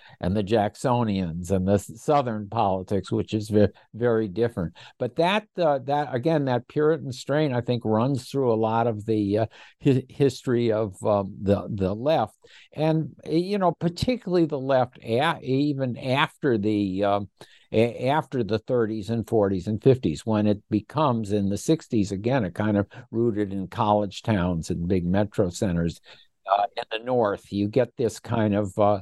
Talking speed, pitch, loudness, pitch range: 170 wpm, 115 Hz, -25 LUFS, 105-130 Hz